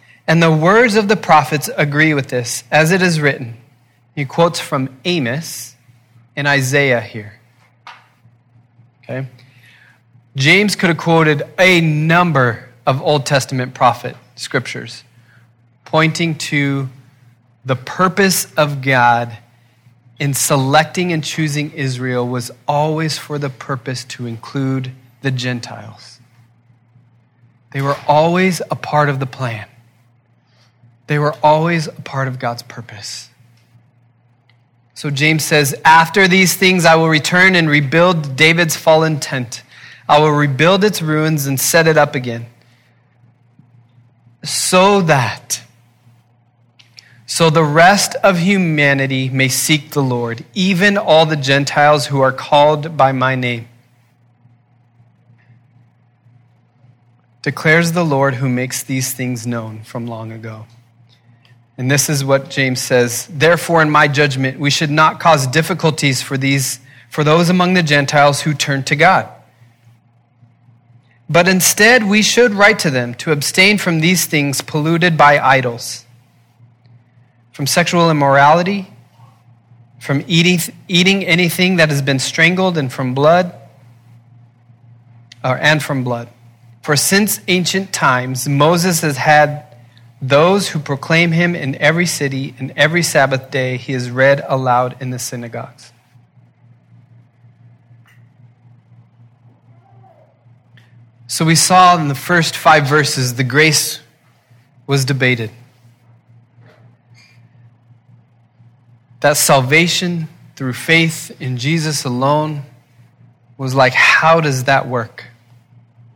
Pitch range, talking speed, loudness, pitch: 120-155 Hz, 120 wpm, -13 LUFS, 130 Hz